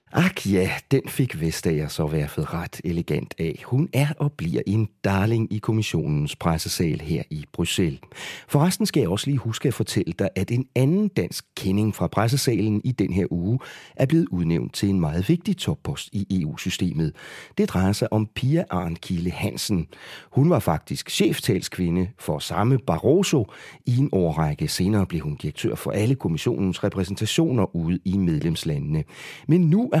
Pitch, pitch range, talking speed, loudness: 105 Hz, 90-140 Hz, 165 wpm, -24 LUFS